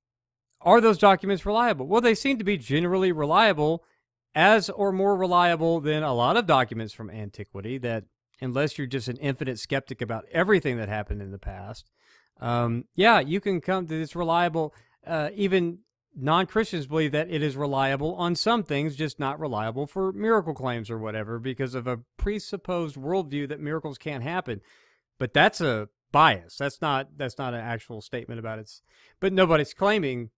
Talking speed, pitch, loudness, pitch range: 175 wpm, 150 Hz, -25 LUFS, 120-180 Hz